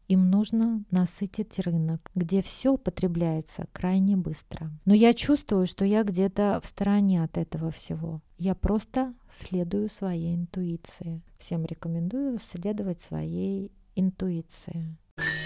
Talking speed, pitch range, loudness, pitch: 115 wpm, 165-205 Hz, -28 LUFS, 185 Hz